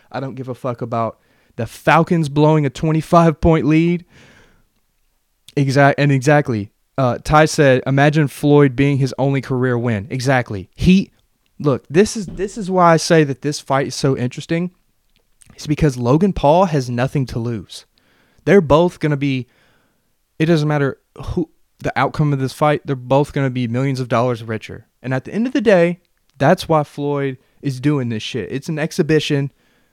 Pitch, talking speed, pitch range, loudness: 140 Hz, 175 wpm, 125-155 Hz, -17 LUFS